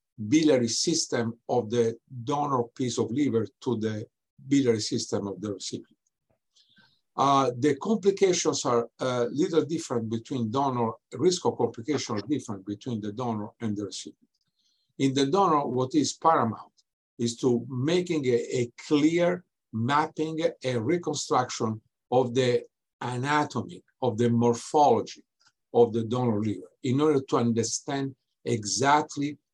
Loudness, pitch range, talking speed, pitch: -27 LUFS, 115-150 Hz, 130 wpm, 125 Hz